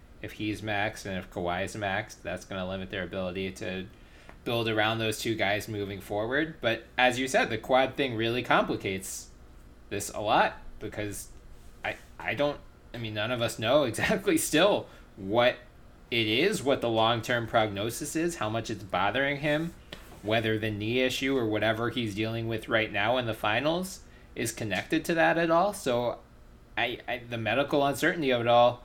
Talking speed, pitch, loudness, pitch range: 185 wpm, 110 Hz, -28 LUFS, 105-125 Hz